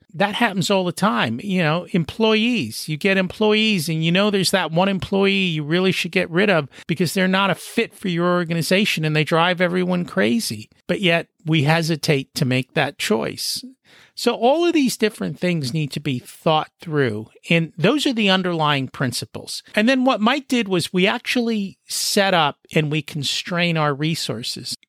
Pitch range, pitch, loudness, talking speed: 160-205 Hz, 180 Hz, -20 LUFS, 185 wpm